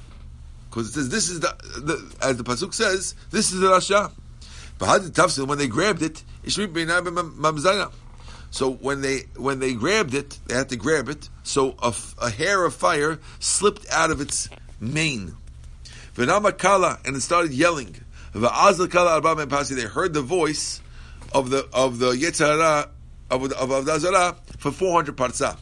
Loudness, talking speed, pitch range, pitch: -22 LUFS, 145 wpm, 110-175 Hz, 140 Hz